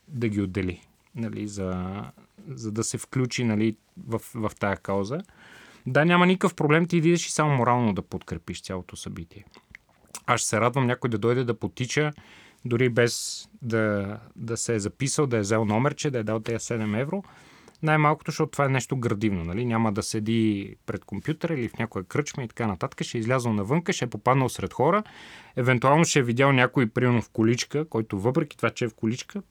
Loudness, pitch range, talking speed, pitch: -25 LUFS, 110-145 Hz, 195 wpm, 120 Hz